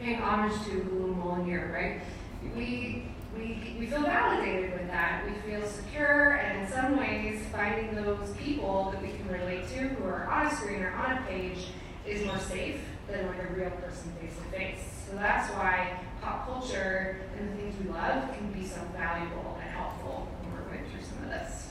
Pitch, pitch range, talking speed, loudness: 190 Hz, 175-210 Hz, 190 wpm, -32 LUFS